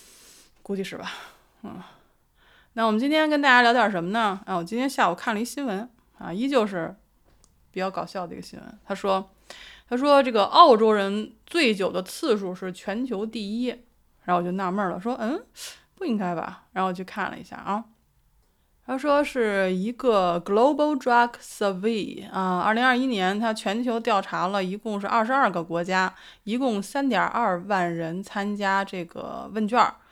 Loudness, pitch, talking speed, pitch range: -24 LUFS, 210 Hz, 280 characters per minute, 185-240 Hz